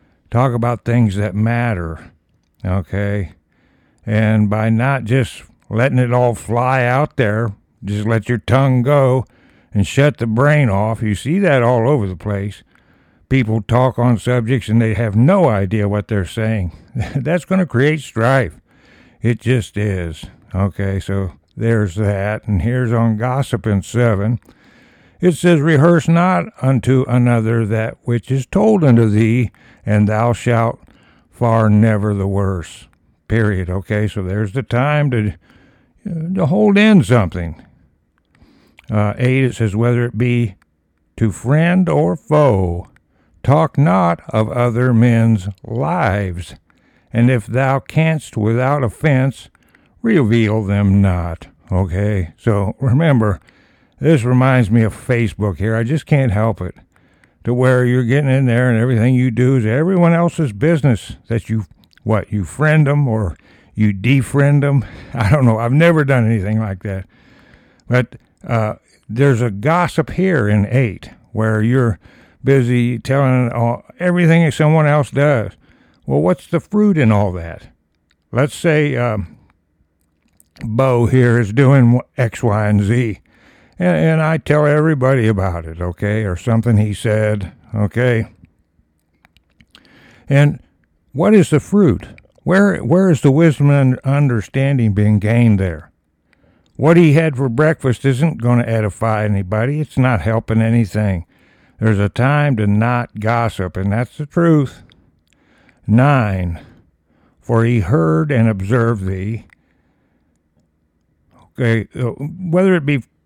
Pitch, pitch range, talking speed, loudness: 115 Hz, 105-135 Hz, 140 wpm, -15 LUFS